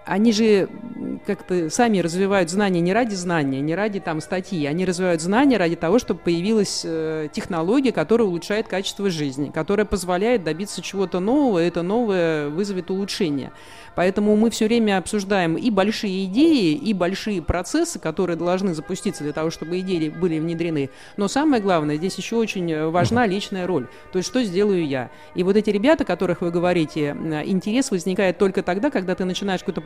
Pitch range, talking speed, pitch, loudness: 170-210 Hz, 170 wpm, 190 Hz, -21 LUFS